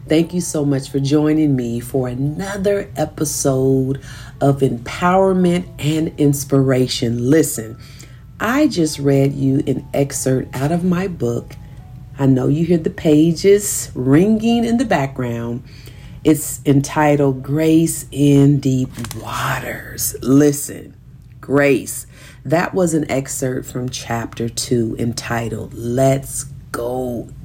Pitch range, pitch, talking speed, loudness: 125-155 Hz, 135 Hz, 115 wpm, -17 LUFS